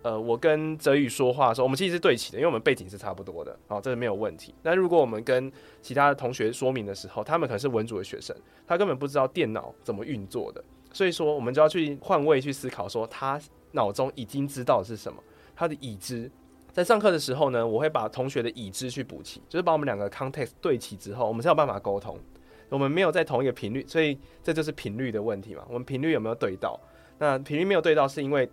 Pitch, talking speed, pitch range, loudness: 135 Hz, 400 characters per minute, 115-155 Hz, -27 LUFS